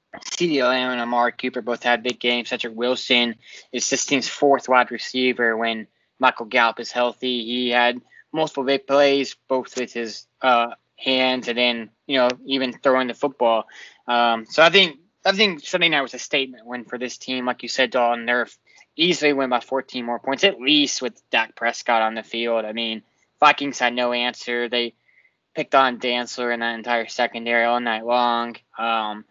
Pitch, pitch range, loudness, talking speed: 125 Hz, 120-135 Hz, -21 LUFS, 185 wpm